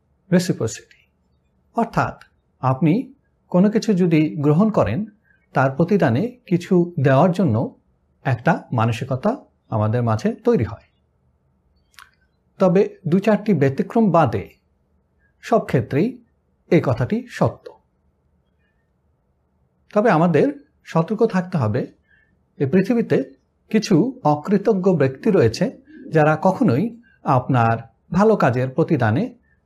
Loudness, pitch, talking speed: -19 LUFS, 160 Hz, 90 wpm